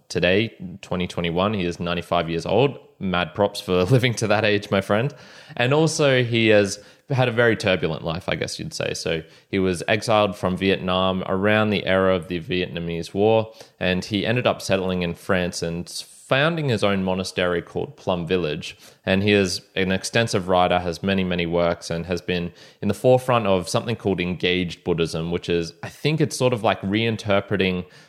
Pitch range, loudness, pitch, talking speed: 90-110 Hz, -22 LUFS, 95 Hz, 185 wpm